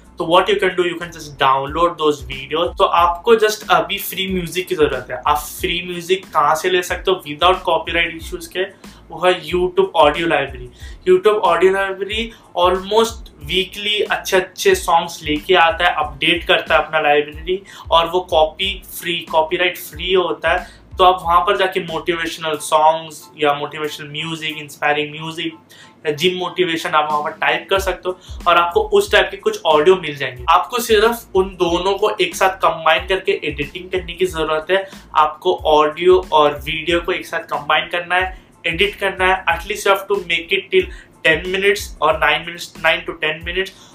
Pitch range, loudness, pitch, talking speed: 155-190 Hz, -17 LUFS, 175 Hz, 185 wpm